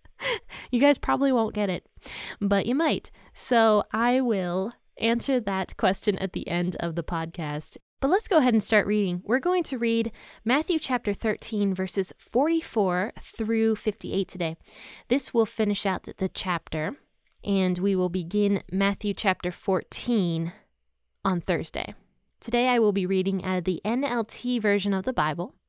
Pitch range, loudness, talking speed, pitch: 185-235 Hz, -26 LUFS, 160 wpm, 205 Hz